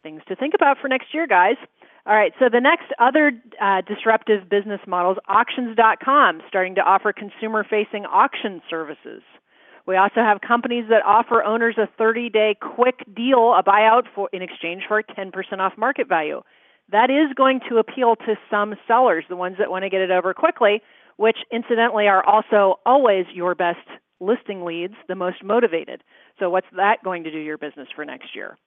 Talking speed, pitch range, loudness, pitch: 185 wpm, 190-235 Hz, -19 LUFS, 210 Hz